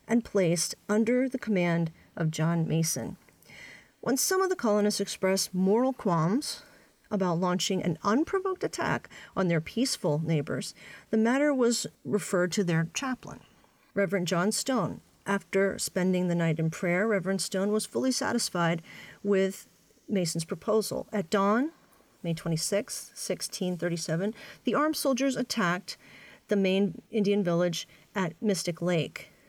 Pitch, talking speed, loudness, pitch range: 195 Hz, 130 wpm, -29 LUFS, 175-225 Hz